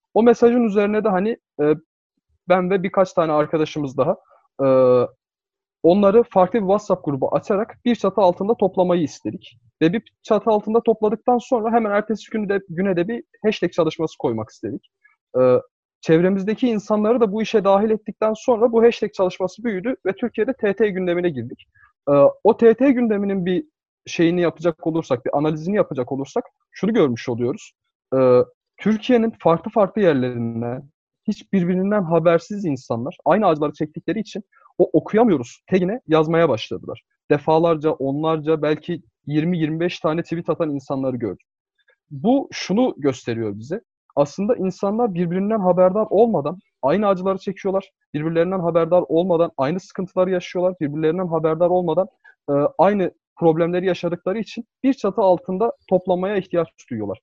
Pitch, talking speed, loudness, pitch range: 185 Hz, 135 wpm, -20 LUFS, 160-220 Hz